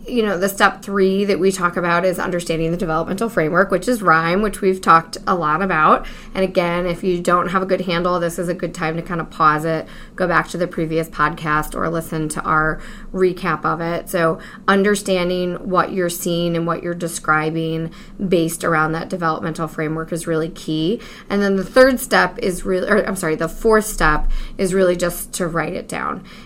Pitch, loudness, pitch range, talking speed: 175 Hz, -18 LUFS, 165-195 Hz, 210 wpm